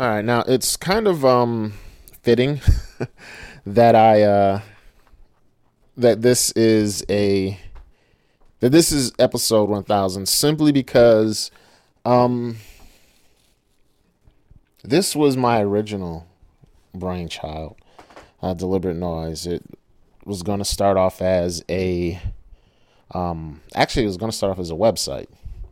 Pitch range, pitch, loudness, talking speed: 90-120 Hz, 100 Hz, -19 LUFS, 120 wpm